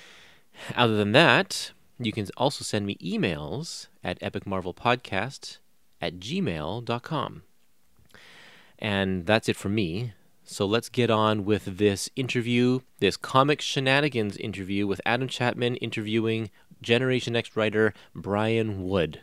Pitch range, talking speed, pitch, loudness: 100-120 Hz, 120 wpm, 110 Hz, -26 LUFS